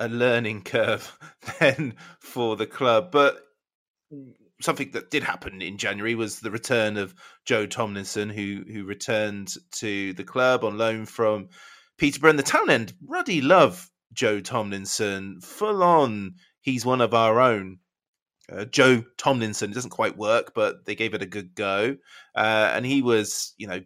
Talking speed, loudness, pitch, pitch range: 160 wpm, -24 LUFS, 110 Hz, 100-120 Hz